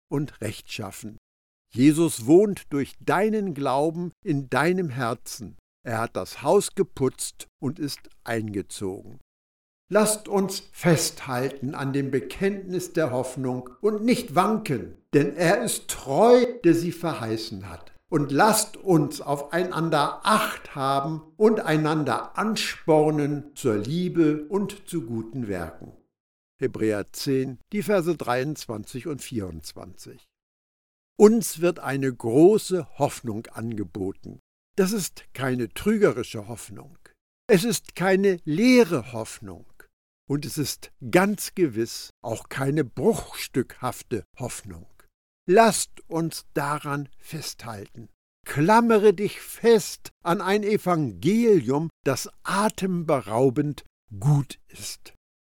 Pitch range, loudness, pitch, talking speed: 115-180 Hz, -24 LUFS, 145 Hz, 105 wpm